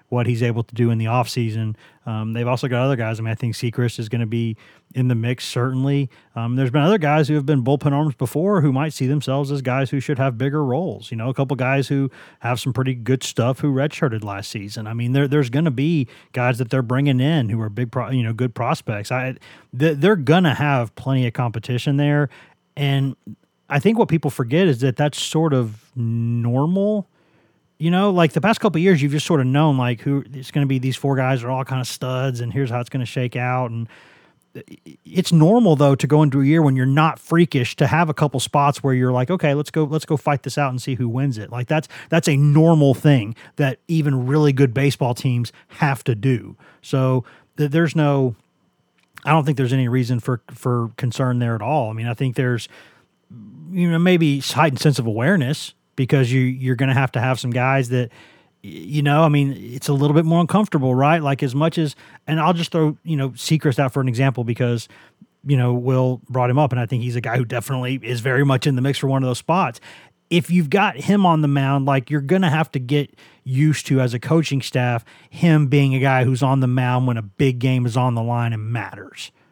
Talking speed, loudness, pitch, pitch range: 240 wpm, -19 LUFS, 135 Hz, 125-150 Hz